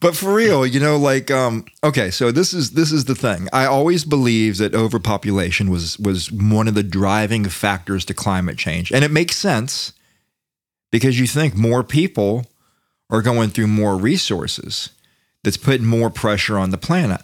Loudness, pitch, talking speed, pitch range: -18 LUFS, 115 Hz, 180 wpm, 100-135 Hz